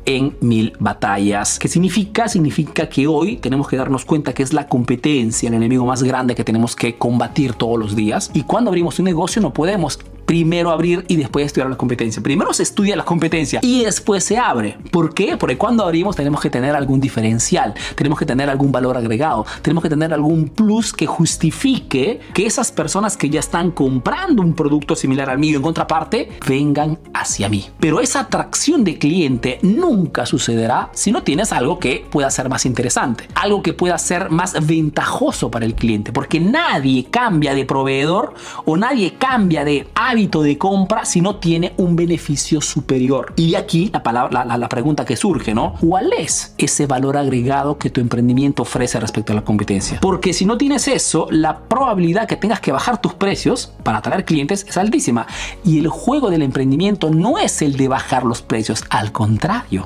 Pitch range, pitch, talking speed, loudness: 130-175 Hz, 150 Hz, 190 wpm, -17 LUFS